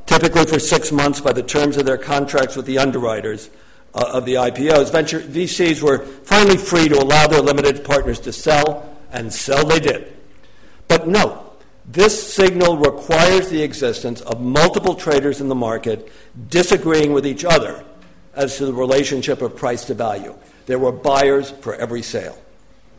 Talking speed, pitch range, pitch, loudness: 165 wpm, 130-160 Hz, 140 Hz, -16 LUFS